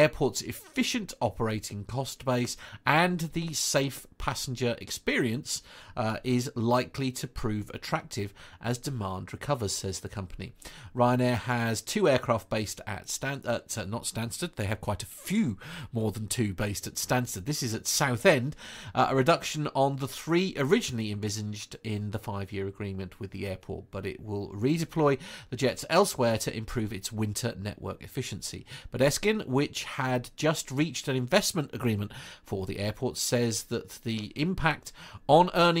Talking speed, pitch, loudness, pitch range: 155 wpm, 120 Hz, -30 LUFS, 105-140 Hz